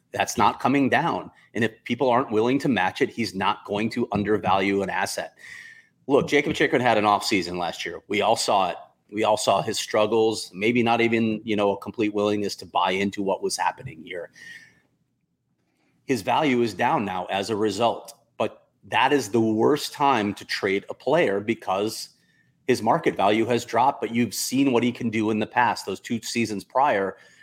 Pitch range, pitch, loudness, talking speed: 105-120 Hz, 110 Hz, -23 LUFS, 195 wpm